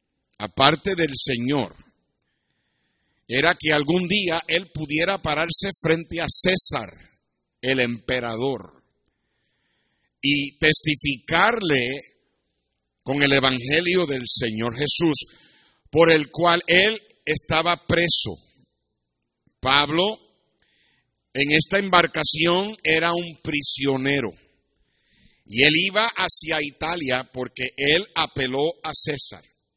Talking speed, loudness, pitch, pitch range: 95 wpm, -19 LUFS, 155 Hz, 135-170 Hz